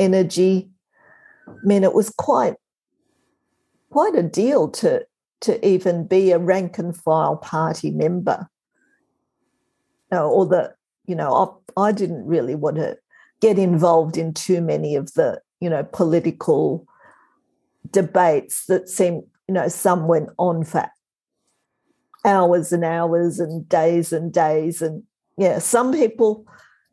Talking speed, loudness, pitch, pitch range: 135 wpm, -20 LUFS, 180 Hz, 165-200 Hz